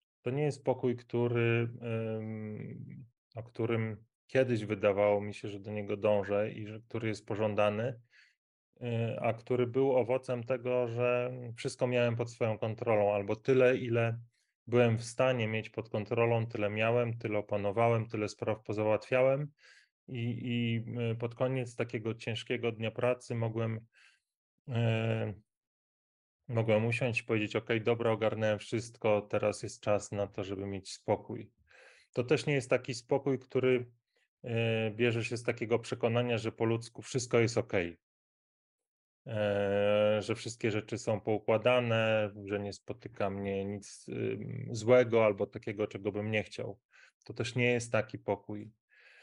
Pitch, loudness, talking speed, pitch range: 115 Hz, -33 LUFS, 140 wpm, 105-120 Hz